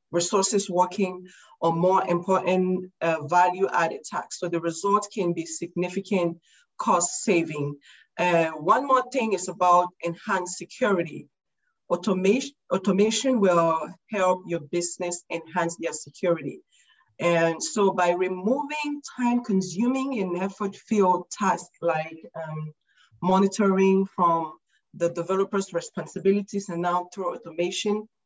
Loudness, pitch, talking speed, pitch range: -25 LUFS, 180 Hz, 115 wpm, 170-200 Hz